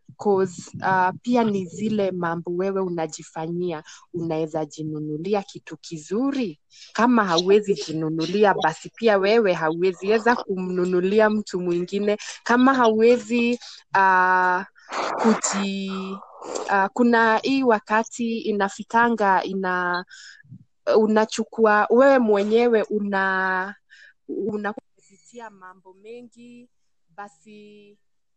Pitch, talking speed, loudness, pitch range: 200 Hz, 80 wpm, -21 LUFS, 180-220 Hz